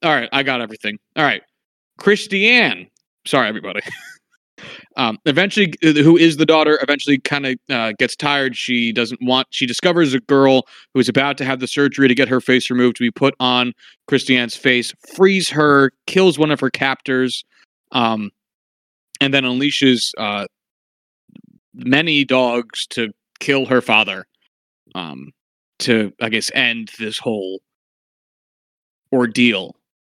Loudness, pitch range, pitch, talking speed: -16 LUFS, 120-145 Hz, 130 Hz, 145 wpm